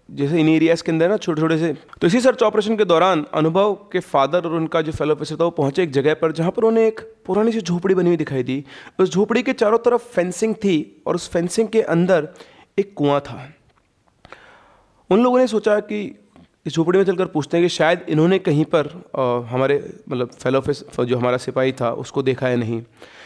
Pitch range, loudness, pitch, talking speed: 140-205 Hz, -19 LUFS, 165 Hz, 215 wpm